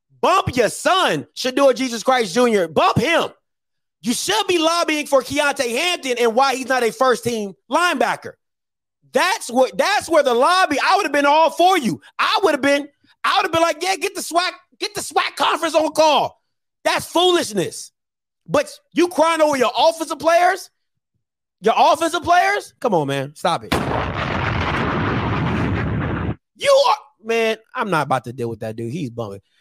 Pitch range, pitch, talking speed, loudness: 245-340 Hz, 290 Hz, 175 wpm, -18 LUFS